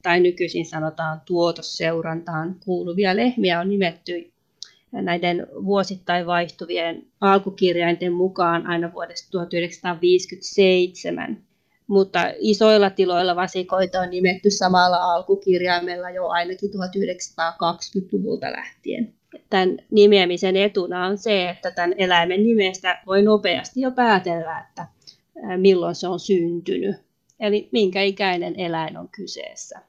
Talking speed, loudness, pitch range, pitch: 105 wpm, -21 LUFS, 175-195 Hz, 180 Hz